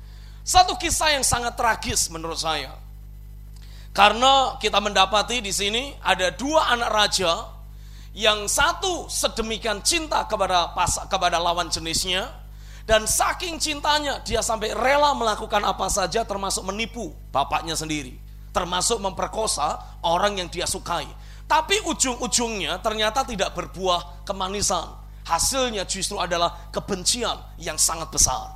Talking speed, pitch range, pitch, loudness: 120 wpm, 165-235 Hz, 195 Hz, -22 LUFS